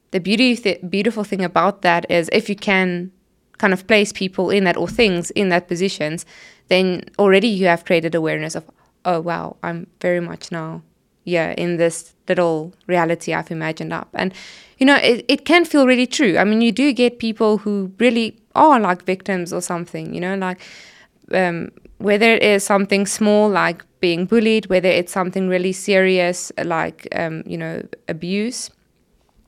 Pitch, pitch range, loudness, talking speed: 190 Hz, 175-215 Hz, -18 LUFS, 175 wpm